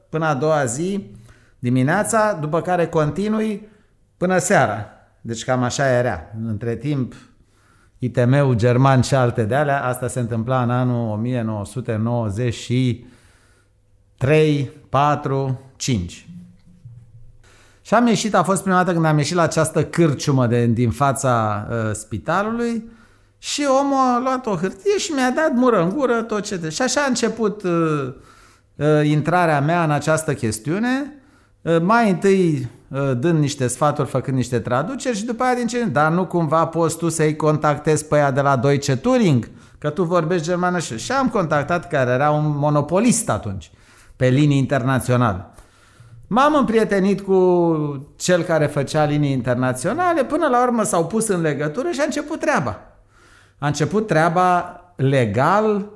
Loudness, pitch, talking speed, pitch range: -19 LUFS, 150 Hz, 150 wpm, 120-185 Hz